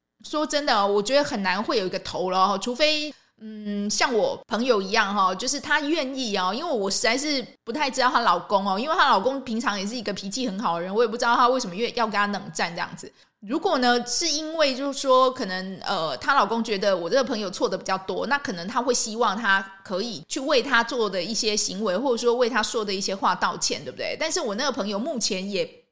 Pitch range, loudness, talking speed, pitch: 200-265 Hz, -24 LUFS, 350 characters per minute, 230 Hz